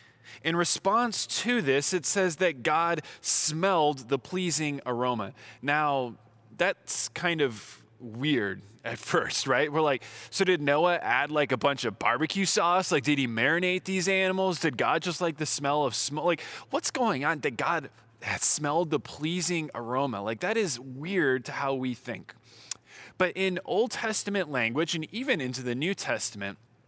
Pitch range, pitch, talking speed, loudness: 125-180 Hz, 150 Hz, 165 wpm, -27 LUFS